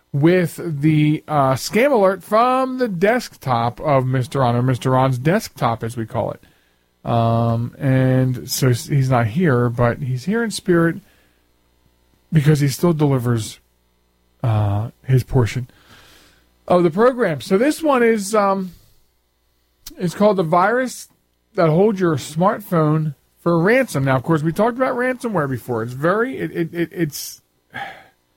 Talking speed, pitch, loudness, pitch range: 140 wpm, 140 Hz, -18 LUFS, 115-180 Hz